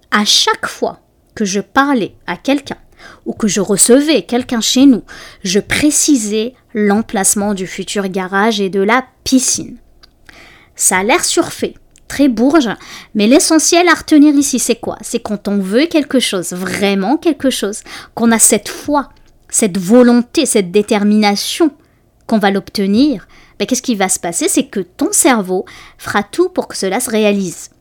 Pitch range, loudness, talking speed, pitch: 200-280 Hz, -13 LUFS, 160 wpm, 230 Hz